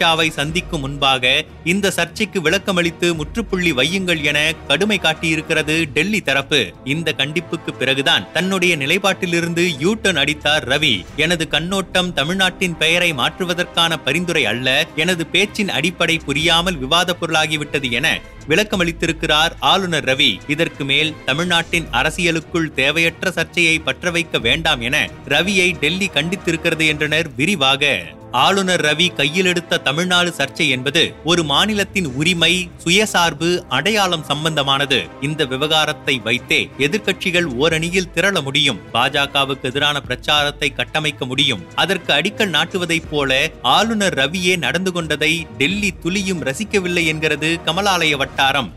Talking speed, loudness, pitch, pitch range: 110 wpm, -16 LUFS, 165 Hz, 145-180 Hz